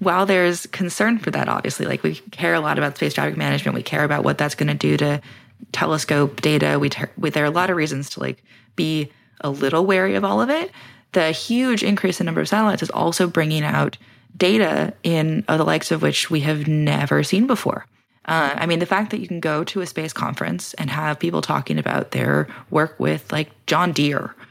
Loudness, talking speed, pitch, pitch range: -20 LUFS, 225 wpm, 155 Hz, 125-180 Hz